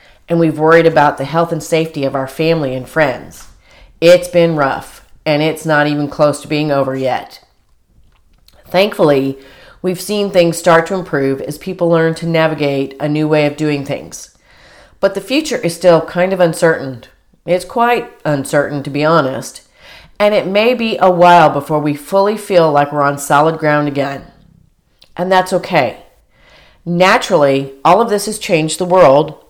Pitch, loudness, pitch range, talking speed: 160 Hz, -13 LUFS, 145-180 Hz, 170 wpm